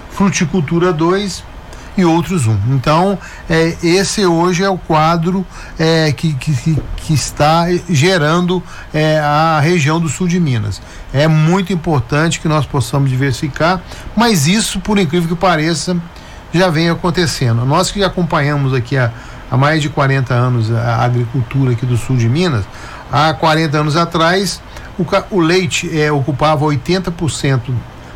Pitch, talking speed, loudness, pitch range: 160 Hz, 150 wpm, -14 LUFS, 140-180 Hz